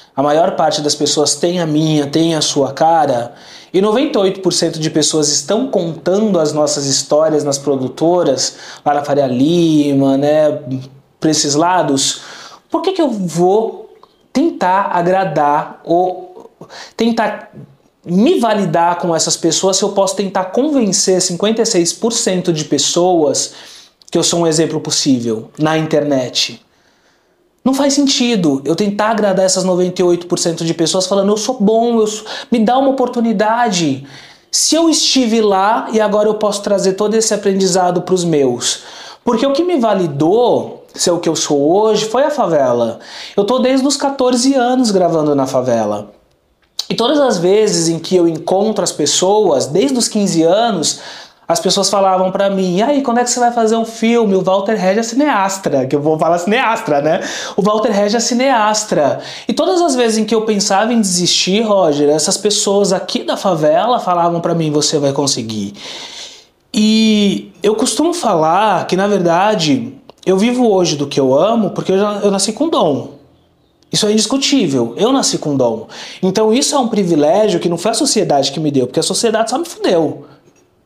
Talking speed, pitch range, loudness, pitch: 170 wpm, 155-220 Hz, -14 LUFS, 190 Hz